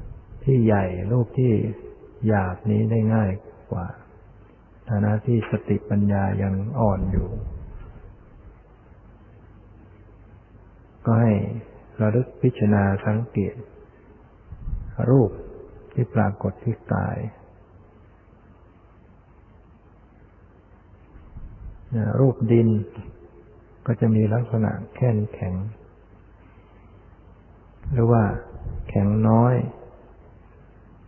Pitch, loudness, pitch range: 105 Hz, -23 LUFS, 100-110 Hz